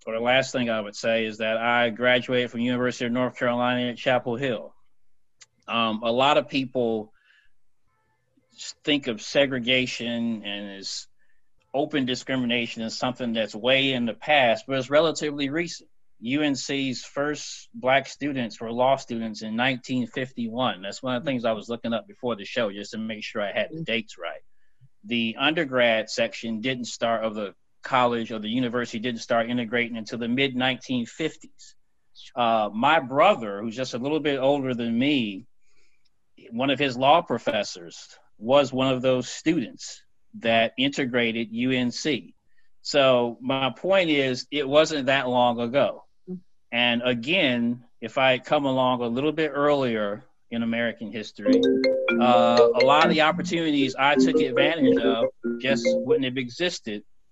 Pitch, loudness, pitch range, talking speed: 125 Hz, -24 LUFS, 115-135 Hz, 160 wpm